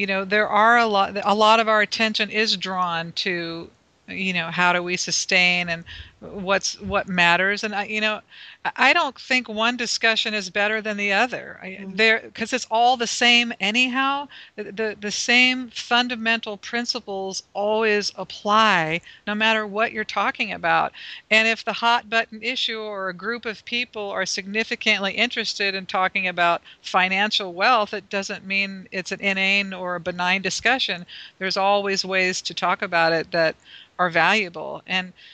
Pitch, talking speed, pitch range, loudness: 205 Hz, 165 wpm, 190-225 Hz, -21 LUFS